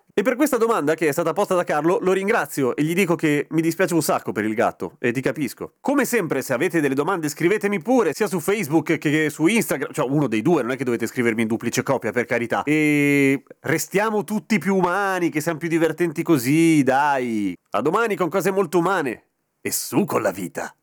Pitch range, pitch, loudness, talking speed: 140-195 Hz, 165 Hz, -21 LUFS, 220 wpm